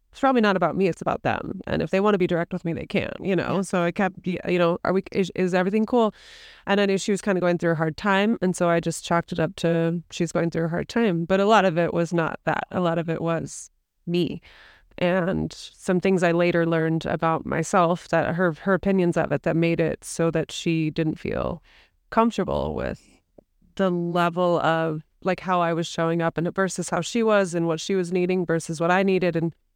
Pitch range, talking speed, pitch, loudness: 165-190 Hz, 245 wpm, 175 Hz, -23 LUFS